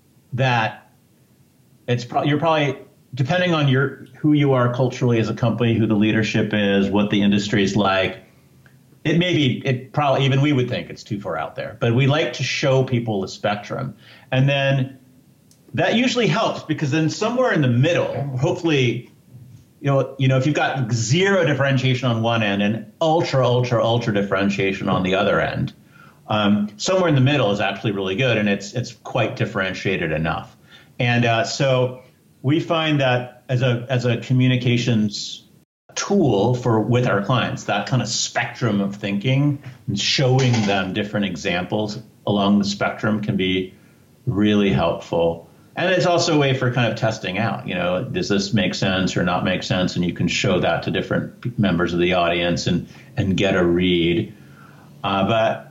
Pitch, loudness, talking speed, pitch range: 125 Hz, -20 LUFS, 180 wpm, 105-140 Hz